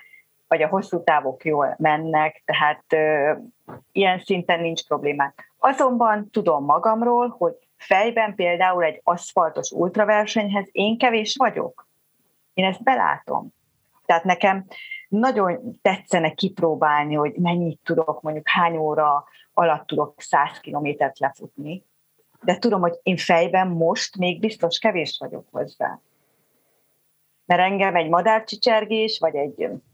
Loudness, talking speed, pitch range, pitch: -21 LUFS, 120 wpm, 155-215 Hz, 180 Hz